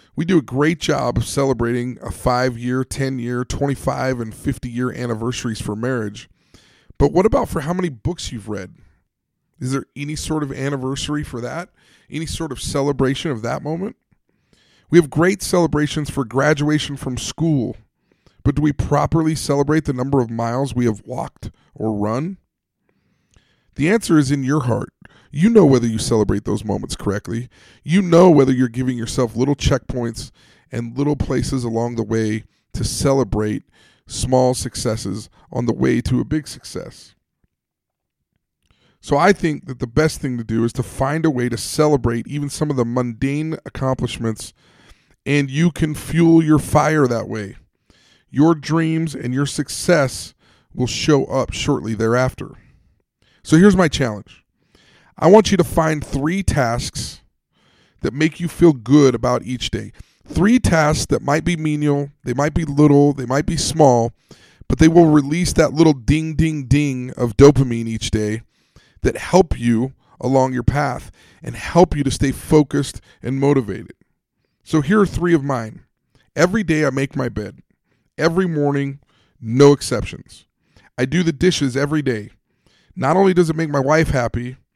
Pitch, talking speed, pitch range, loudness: 135 Hz, 165 wpm, 120-155 Hz, -18 LUFS